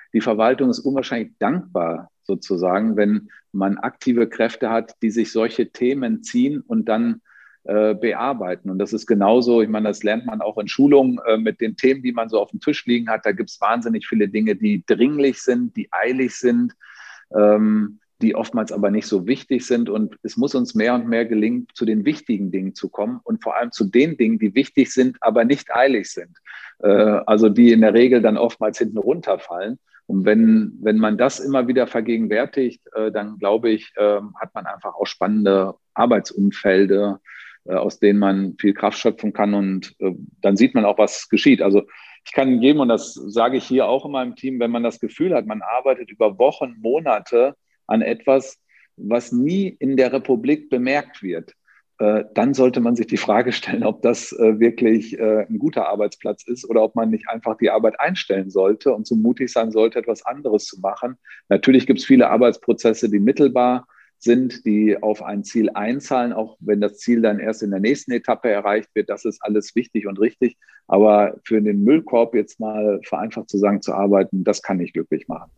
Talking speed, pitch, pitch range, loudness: 195 wpm, 115 Hz, 105-130 Hz, -19 LUFS